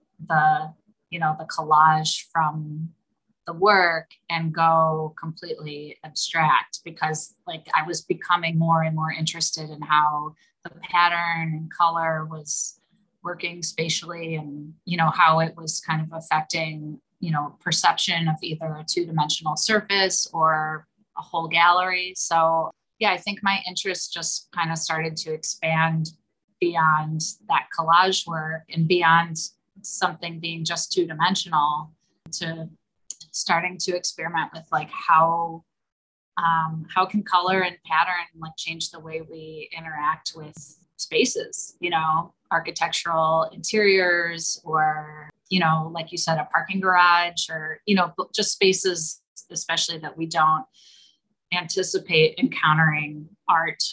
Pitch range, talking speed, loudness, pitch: 160-175 Hz, 130 wpm, -23 LUFS, 165 Hz